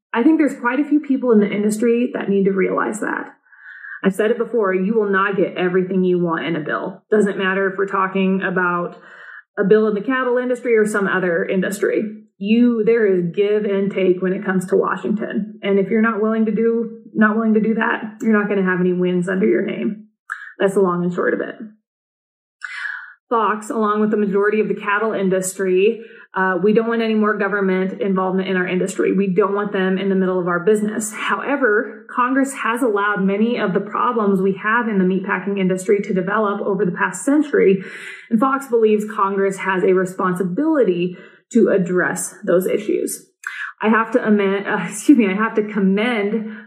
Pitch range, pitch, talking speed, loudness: 190-225 Hz, 205 Hz, 200 wpm, -18 LUFS